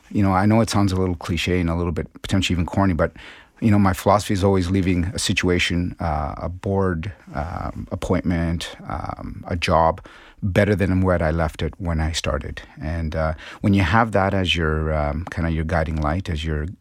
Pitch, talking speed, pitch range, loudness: 90 Hz, 215 wpm, 80-100 Hz, -21 LUFS